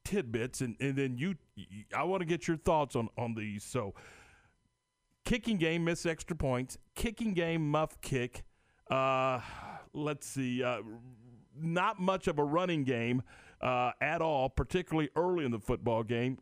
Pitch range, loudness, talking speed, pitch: 120-170 Hz, -34 LUFS, 155 wpm, 135 Hz